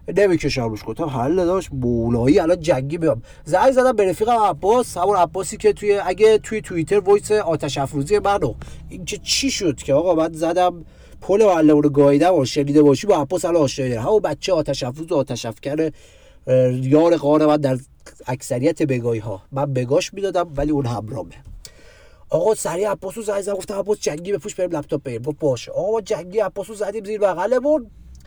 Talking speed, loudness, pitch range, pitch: 180 wpm, -19 LUFS, 140-200 Hz, 165 Hz